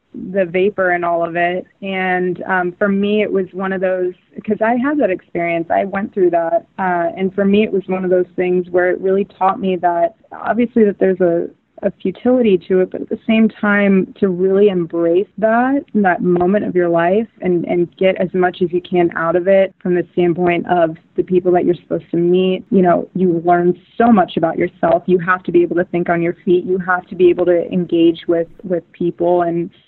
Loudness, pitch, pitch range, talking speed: -16 LUFS, 185 Hz, 175-195 Hz, 225 wpm